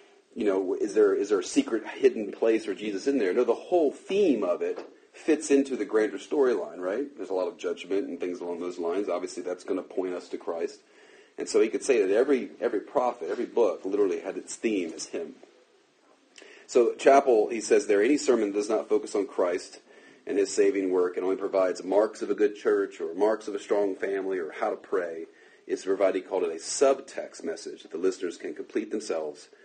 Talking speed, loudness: 220 wpm, -27 LUFS